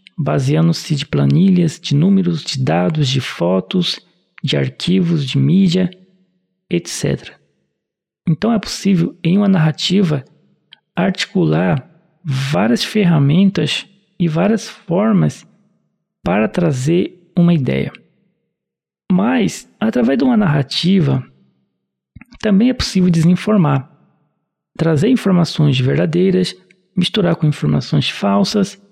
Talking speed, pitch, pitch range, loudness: 95 wpm, 175 Hz, 145-195 Hz, -16 LUFS